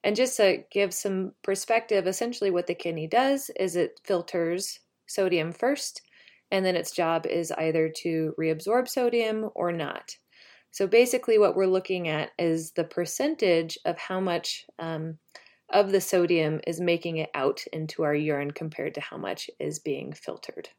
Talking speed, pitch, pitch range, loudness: 165 wpm, 185 Hz, 165-215 Hz, -27 LUFS